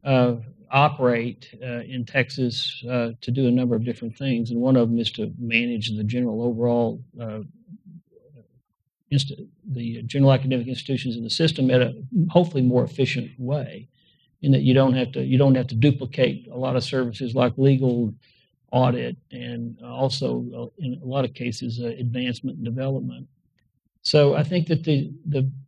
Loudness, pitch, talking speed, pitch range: -23 LUFS, 125 Hz, 170 wpm, 120-135 Hz